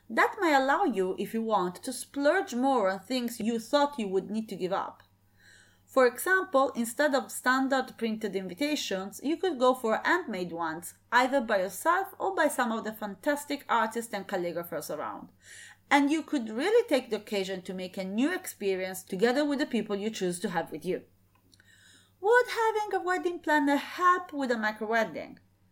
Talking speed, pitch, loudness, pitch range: 180 wpm, 230 Hz, -29 LUFS, 195-290 Hz